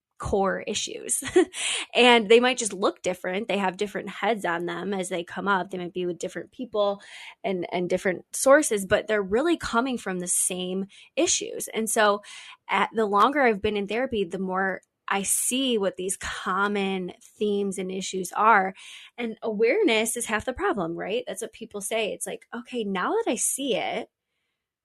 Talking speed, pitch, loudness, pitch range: 180 wpm, 205 Hz, -25 LUFS, 190-235 Hz